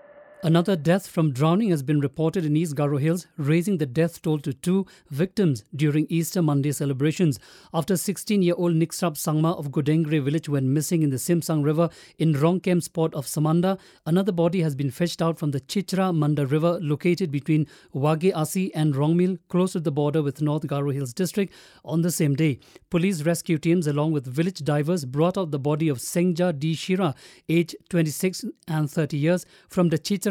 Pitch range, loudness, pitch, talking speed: 150-180 Hz, -24 LUFS, 165 Hz, 180 wpm